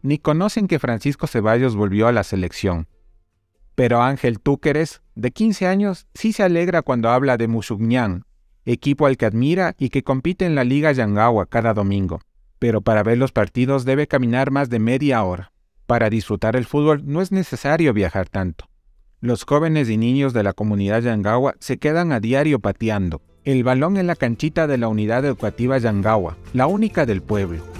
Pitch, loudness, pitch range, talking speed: 120 Hz, -19 LUFS, 105-145 Hz, 175 wpm